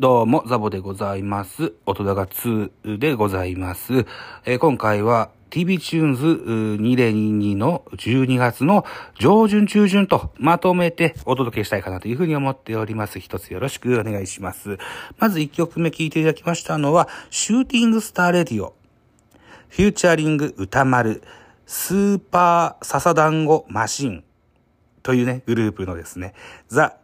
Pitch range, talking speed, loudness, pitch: 105-165 Hz, 320 characters per minute, -20 LUFS, 130 Hz